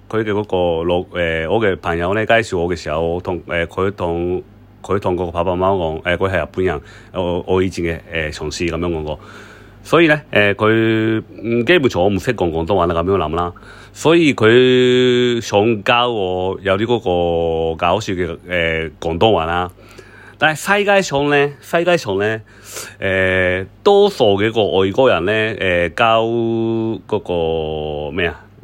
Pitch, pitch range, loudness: 95 Hz, 85-115 Hz, -16 LUFS